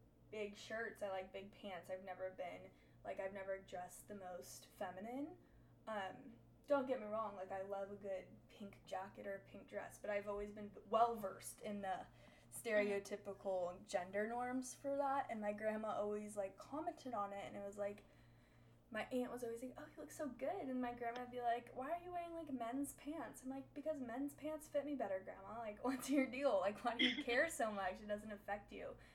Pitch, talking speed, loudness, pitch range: 215 Hz, 210 wpm, -45 LUFS, 200-260 Hz